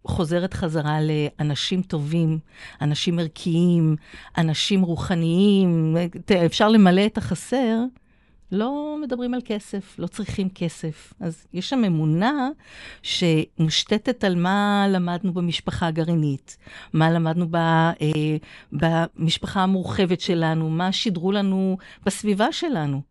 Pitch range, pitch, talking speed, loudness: 165-200 Hz, 180 Hz, 100 wpm, -22 LUFS